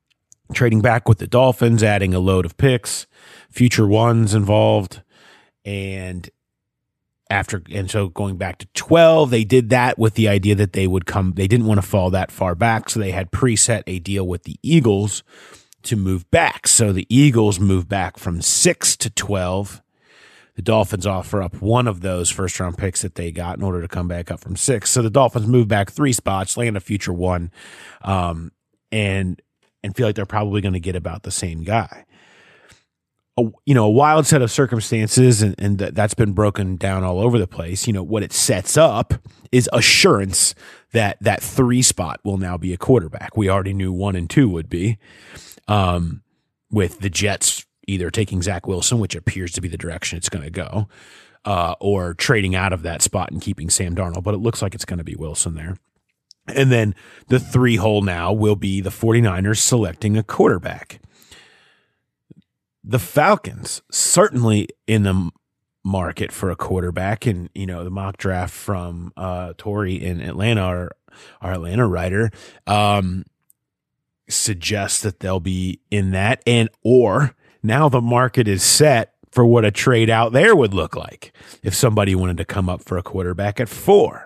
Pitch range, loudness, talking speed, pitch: 95-115 Hz, -18 LUFS, 185 wpm, 100 Hz